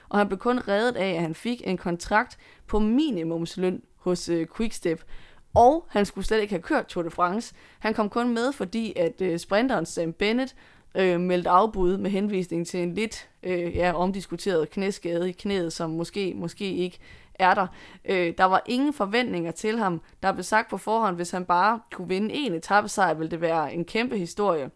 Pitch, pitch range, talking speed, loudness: 185 Hz, 175-215 Hz, 195 wpm, -26 LUFS